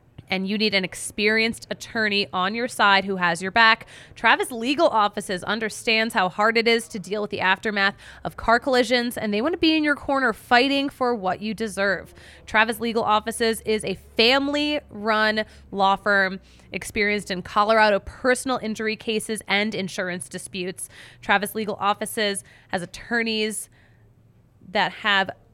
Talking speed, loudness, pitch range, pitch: 155 wpm, -22 LUFS, 195-230 Hz, 215 Hz